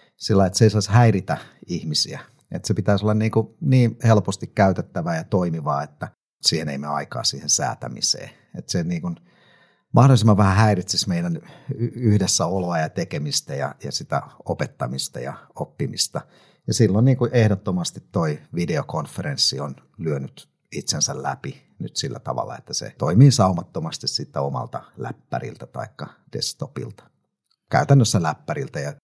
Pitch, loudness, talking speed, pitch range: 110 Hz, -21 LUFS, 140 wpm, 95-135 Hz